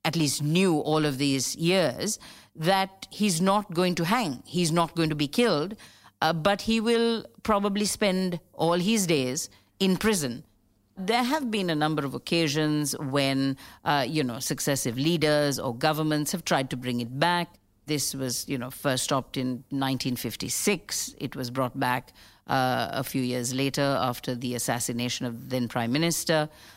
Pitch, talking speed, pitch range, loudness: 150 Hz, 175 wpm, 130-175 Hz, -26 LUFS